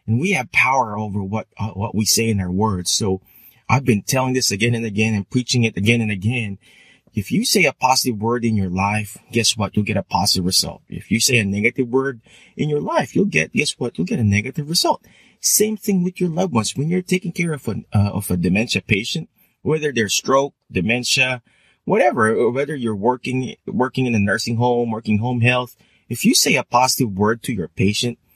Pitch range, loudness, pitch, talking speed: 105-130 Hz, -19 LUFS, 120 Hz, 220 wpm